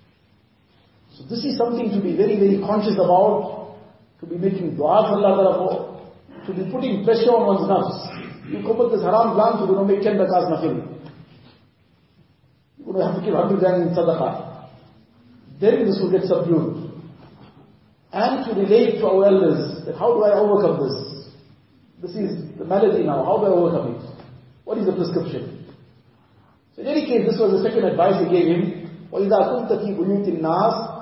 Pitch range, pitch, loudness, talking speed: 155-210 Hz, 180 Hz, -19 LUFS, 160 wpm